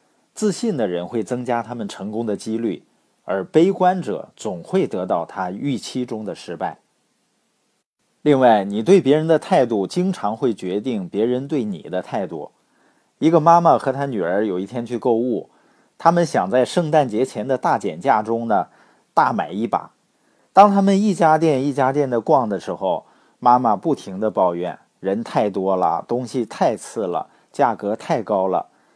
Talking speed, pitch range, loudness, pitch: 240 characters per minute, 115-170 Hz, -20 LUFS, 135 Hz